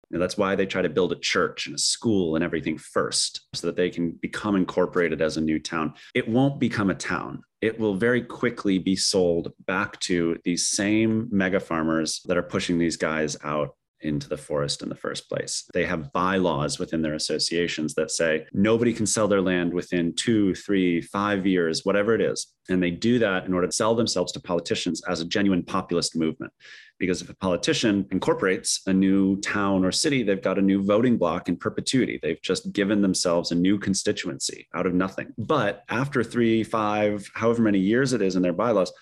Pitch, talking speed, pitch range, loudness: 95 Hz, 205 wpm, 90-105 Hz, -24 LUFS